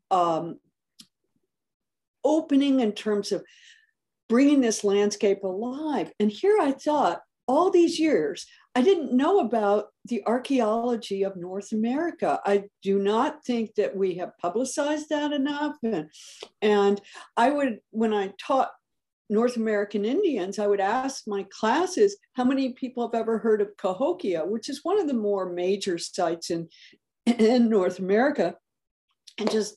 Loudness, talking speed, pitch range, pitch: -25 LUFS, 145 wpm, 205-285 Hz, 230 Hz